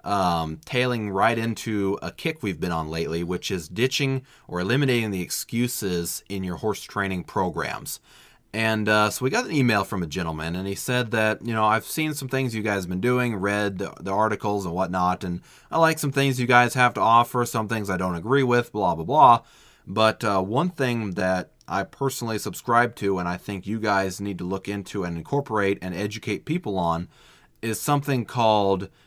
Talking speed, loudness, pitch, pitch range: 205 wpm, -24 LUFS, 105 Hz, 95-125 Hz